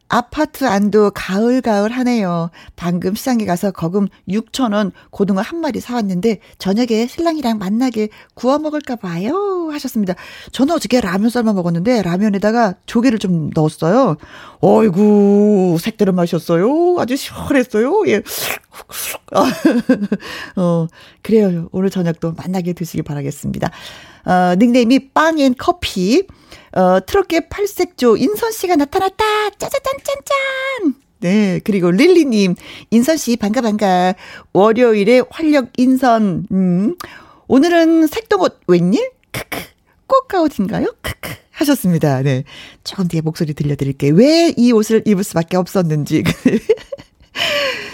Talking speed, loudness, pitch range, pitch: 280 characters per minute, -15 LUFS, 185-275 Hz, 220 Hz